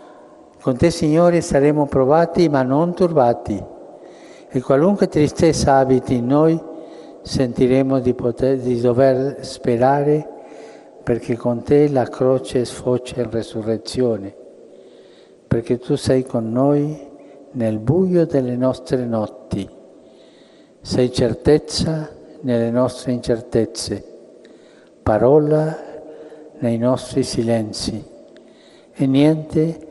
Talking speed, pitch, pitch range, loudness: 100 wpm, 135 Hz, 120-155 Hz, -18 LUFS